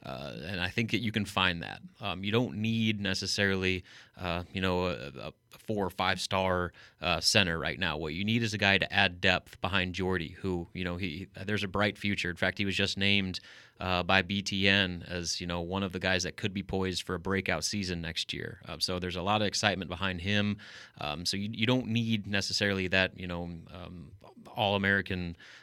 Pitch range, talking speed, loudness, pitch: 90-100 Hz, 220 wpm, -30 LUFS, 95 Hz